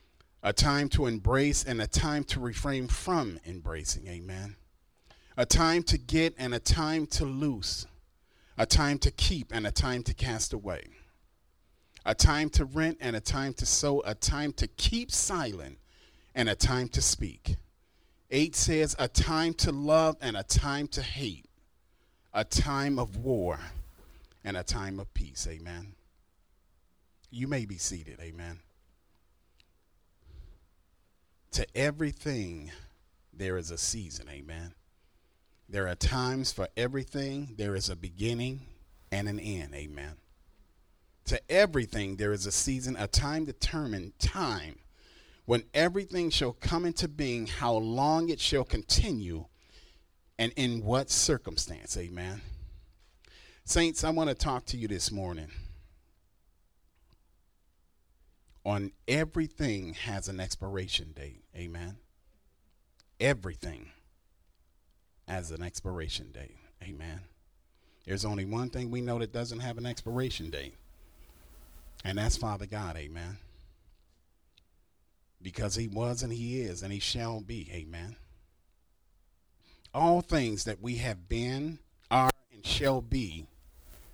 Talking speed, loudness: 130 wpm, -31 LUFS